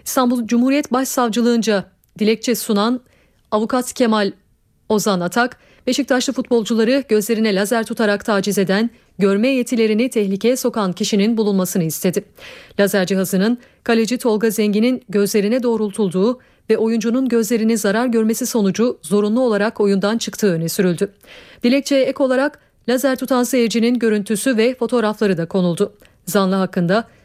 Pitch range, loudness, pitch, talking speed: 205-245 Hz, -18 LUFS, 225 Hz, 120 wpm